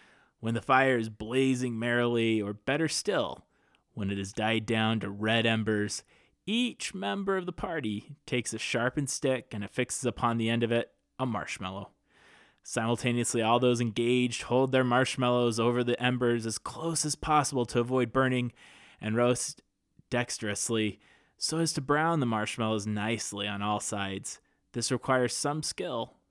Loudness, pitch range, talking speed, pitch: -29 LUFS, 110-130 Hz, 155 wpm, 120 Hz